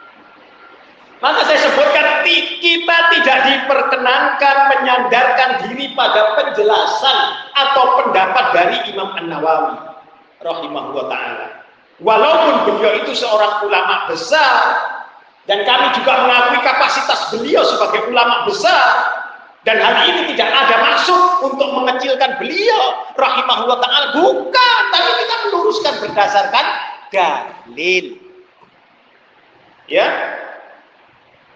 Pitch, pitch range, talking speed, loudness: 260 Hz, 220-300 Hz, 95 wpm, -13 LUFS